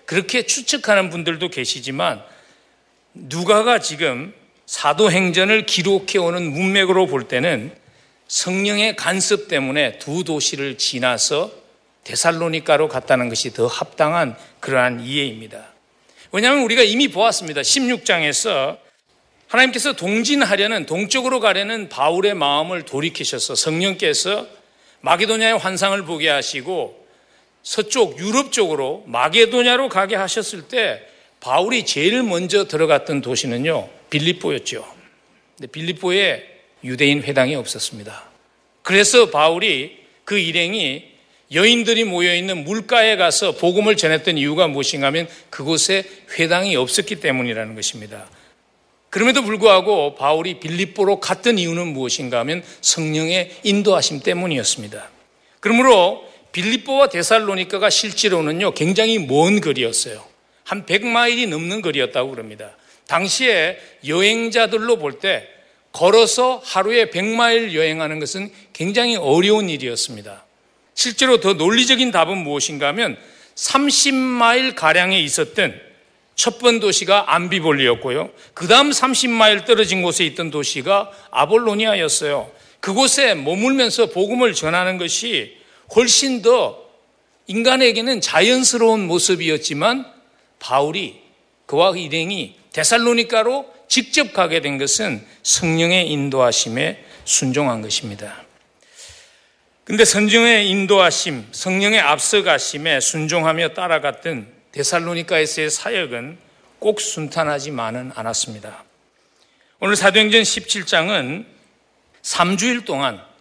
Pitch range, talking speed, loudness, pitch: 155-225 Hz, 295 characters per minute, -17 LUFS, 190 Hz